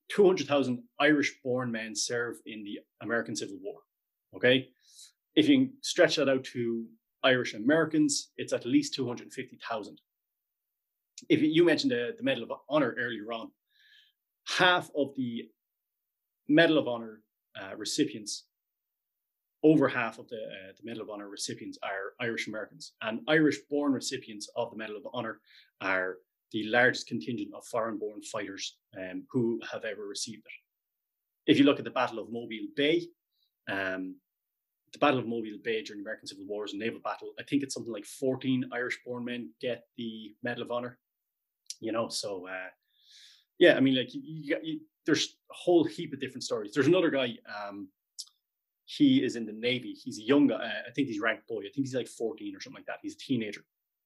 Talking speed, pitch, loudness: 180 wpm, 145 Hz, -30 LUFS